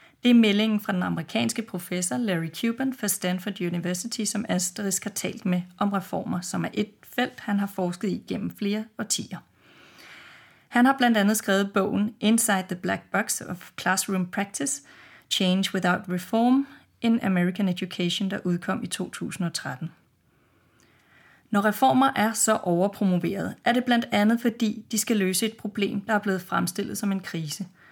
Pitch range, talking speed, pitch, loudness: 185-225 Hz, 160 wpm, 205 Hz, -25 LUFS